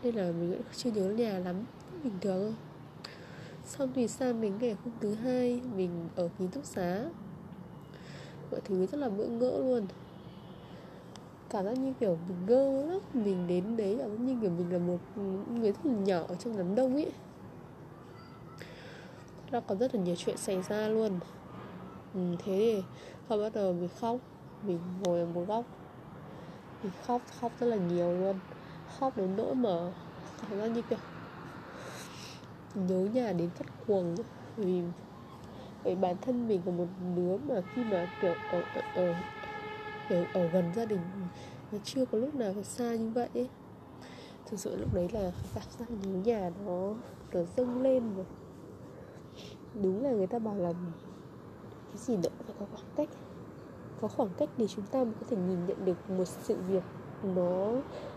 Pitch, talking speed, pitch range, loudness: 200 Hz, 175 wpm, 180-235 Hz, -34 LUFS